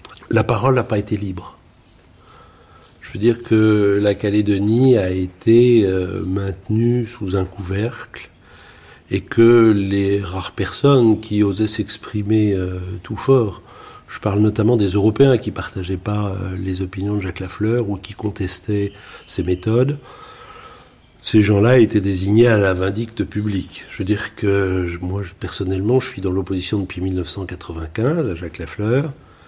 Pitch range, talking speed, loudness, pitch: 95-110 Hz, 140 wpm, -18 LUFS, 100 Hz